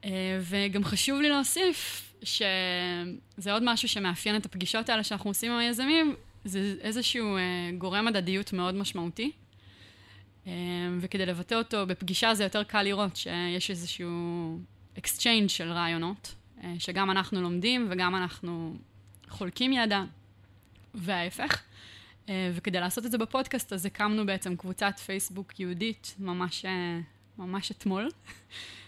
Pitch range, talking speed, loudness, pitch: 175-210 Hz, 115 wpm, -30 LUFS, 190 Hz